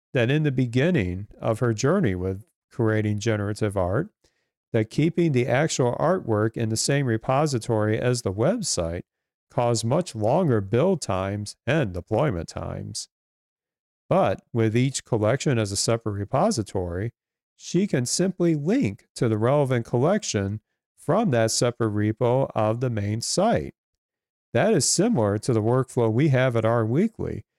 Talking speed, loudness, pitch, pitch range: 145 wpm, -24 LUFS, 115 Hz, 110-135 Hz